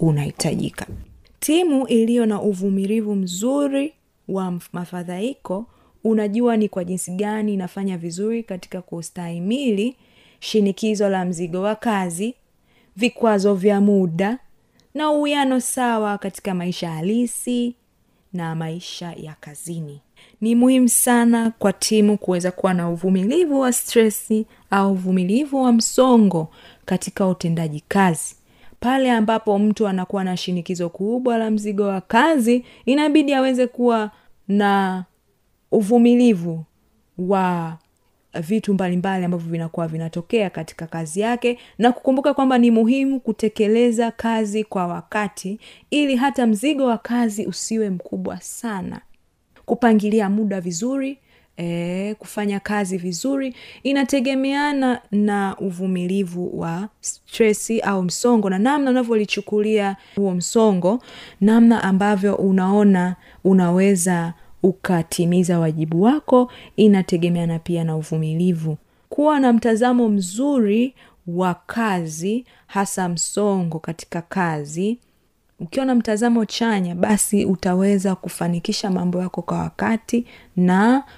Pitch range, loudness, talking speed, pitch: 180-235 Hz, -20 LUFS, 110 wpm, 205 Hz